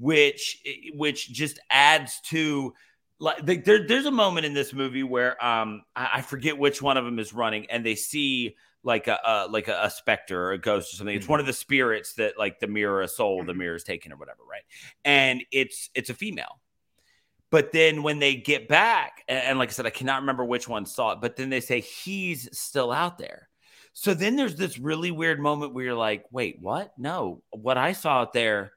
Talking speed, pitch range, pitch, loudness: 220 wpm, 120-155 Hz, 135 Hz, -25 LUFS